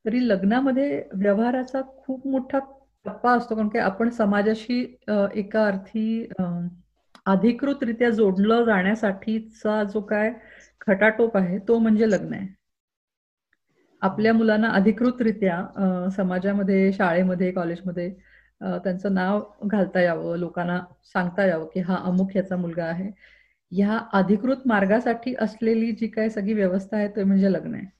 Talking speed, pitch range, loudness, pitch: 125 wpm, 190-225 Hz, -23 LUFS, 210 Hz